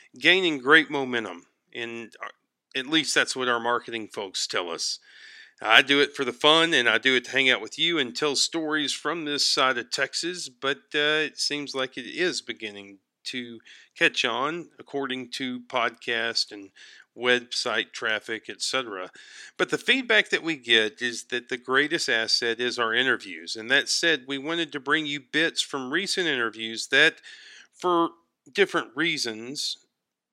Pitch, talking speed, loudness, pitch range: 135 Hz, 165 wpm, -24 LUFS, 115-155 Hz